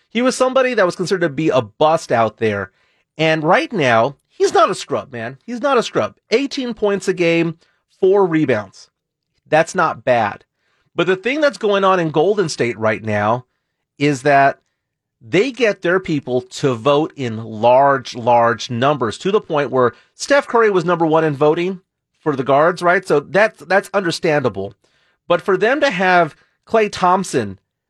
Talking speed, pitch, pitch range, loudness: 175 wpm, 165 Hz, 135-195 Hz, -16 LUFS